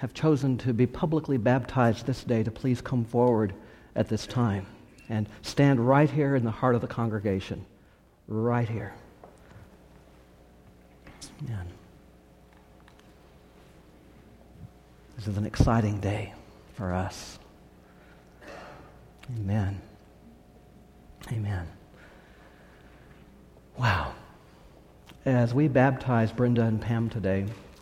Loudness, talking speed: -27 LUFS, 95 wpm